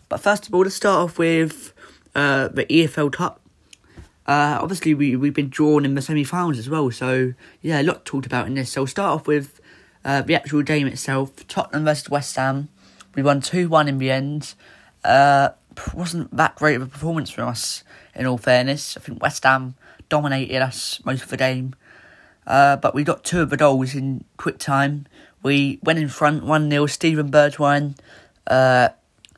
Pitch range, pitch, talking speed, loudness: 130-155 Hz, 140 Hz, 190 wpm, -20 LUFS